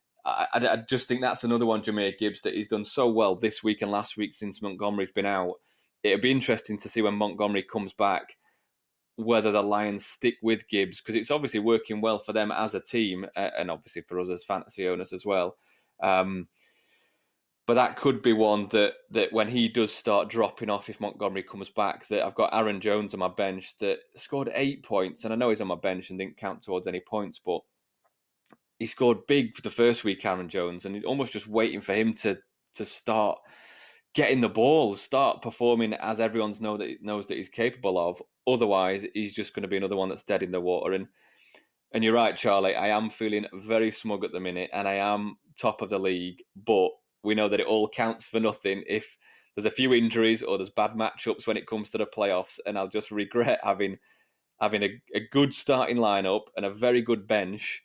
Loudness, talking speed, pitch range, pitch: -28 LUFS, 215 wpm, 100-115 Hz, 105 Hz